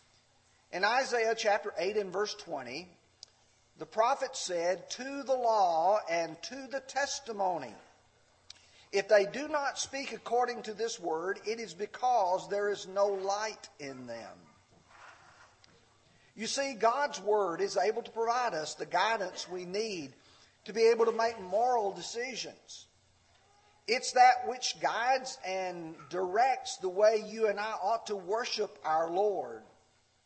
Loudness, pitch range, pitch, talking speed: -32 LUFS, 190-255 Hz, 220 Hz, 140 wpm